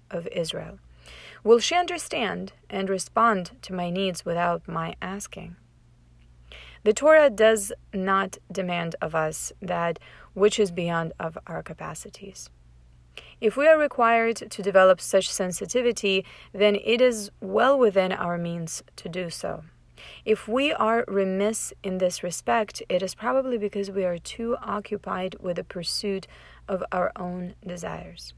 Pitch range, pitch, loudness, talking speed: 170-215 Hz, 190 Hz, -25 LUFS, 140 wpm